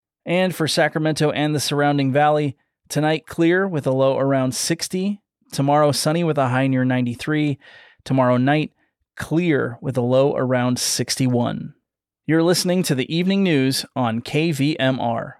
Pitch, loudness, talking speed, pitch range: 145 Hz, -20 LUFS, 145 wpm, 130-160 Hz